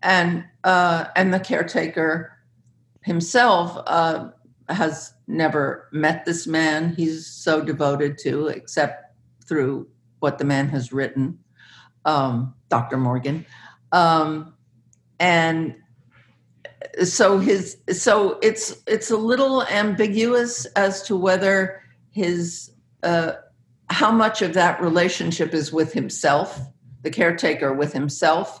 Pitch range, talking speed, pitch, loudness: 135-185 Hz, 110 wpm, 160 Hz, -21 LUFS